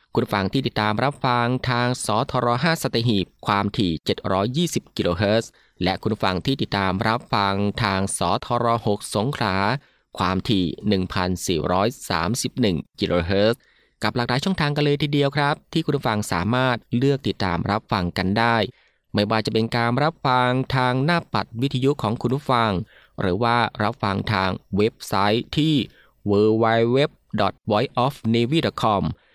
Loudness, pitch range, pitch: -22 LUFS, 100-130 Hz, 115 Hz